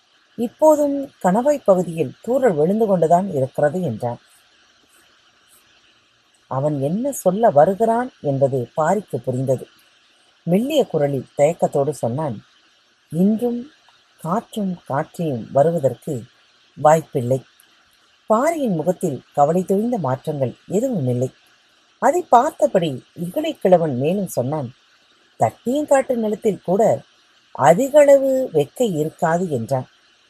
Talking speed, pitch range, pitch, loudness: 85 wpm, 145-235 Hz, 175 Hz, -19 LUFS